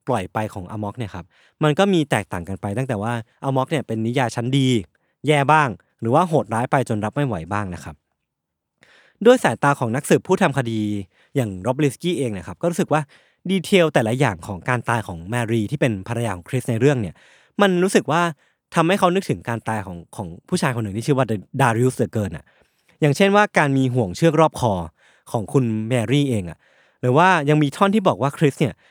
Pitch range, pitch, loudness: 110-155 Hz, 130 Hz, -20 LUFS